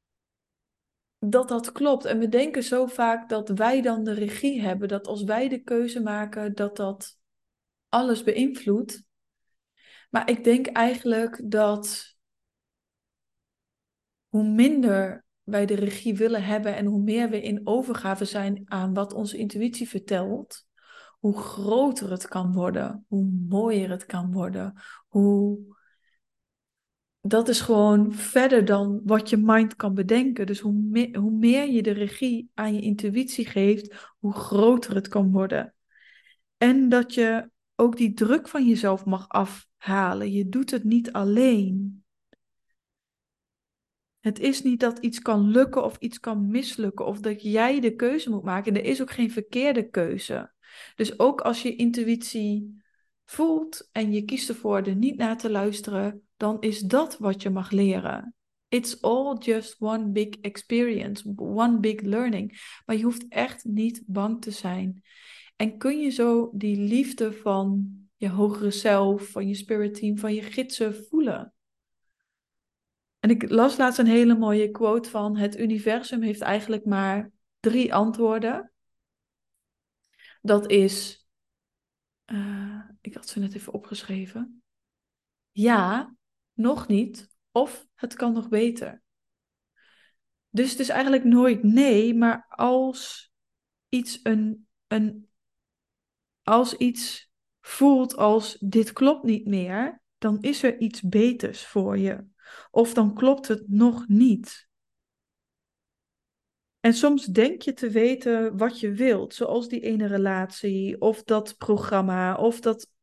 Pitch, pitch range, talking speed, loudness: 220 Hz, 205-240 Hz, 140 wpm, -24 LUFS